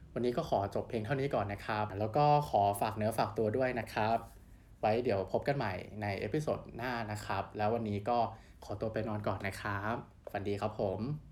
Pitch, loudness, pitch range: 110 Hz, -35 LUFS, 105-120 Hz